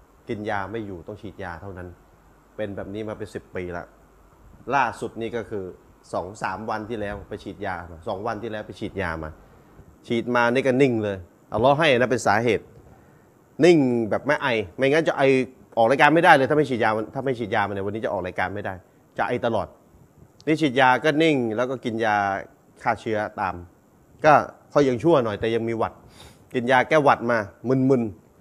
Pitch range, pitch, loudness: 95-125 Hz, 110 Hz, -22 LUFS